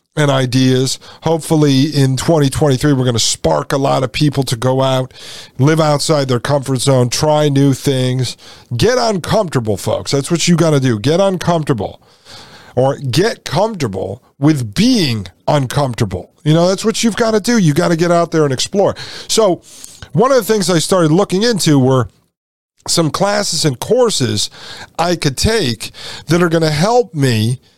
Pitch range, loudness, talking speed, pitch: 130-170 Hz, -14 LUFS, 175 wpm, 145 Hz